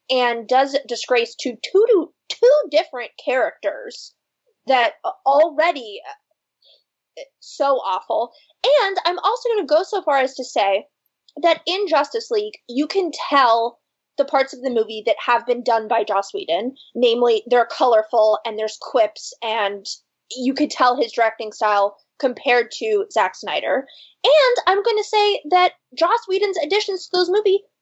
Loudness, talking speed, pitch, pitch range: -19 LUFS, 155 wpm, 285 Hz, 240-380 Hz